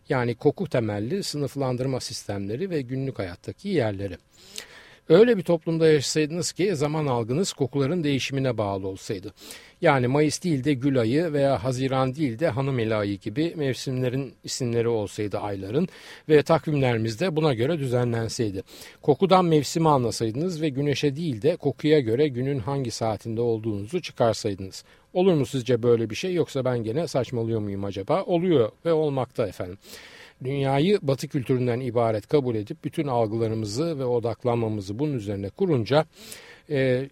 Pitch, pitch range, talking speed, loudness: 135 Hz, 115-155 Hz, 140 wpm, -25 LUFS